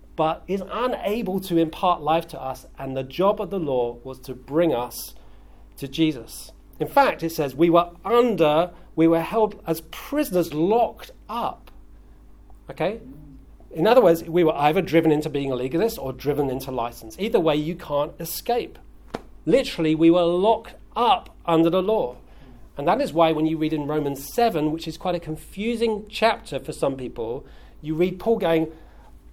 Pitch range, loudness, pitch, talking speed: 145-185 Hz, -23 LUFS, 165 Hz, 175 wpm